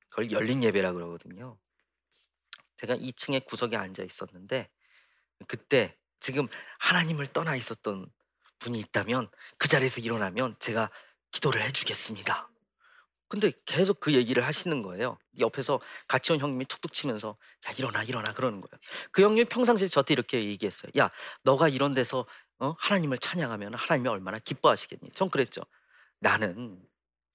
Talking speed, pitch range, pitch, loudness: 345 characters per minute, 110-150 Hz, 130 Hz, -29 LUFS